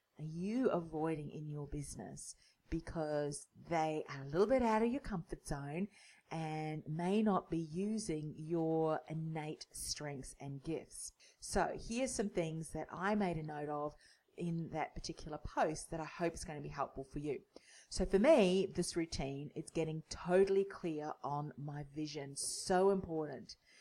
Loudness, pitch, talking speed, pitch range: -39 LUFS, 160 Hz, 165 wpm, 150-180 Hz